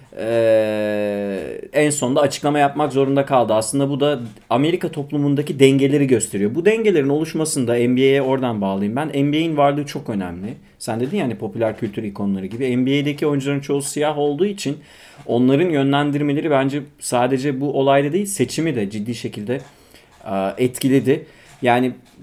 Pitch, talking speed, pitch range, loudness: 140 Hz, 140 wpm, 120-145 Hz, -19 LUFS